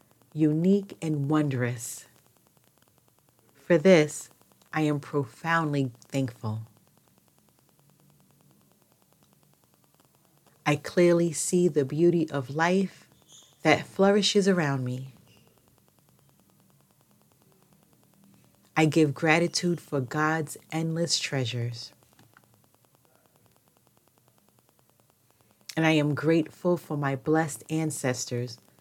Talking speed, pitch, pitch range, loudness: 75 wpm, 150 Hz, 135-165 Hz, -26 LUFS